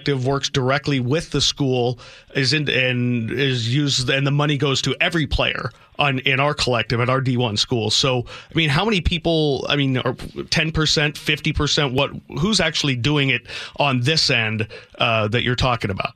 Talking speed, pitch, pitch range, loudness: 185 wpm, 135 Hz, 125-150 Hz, -19 LUFS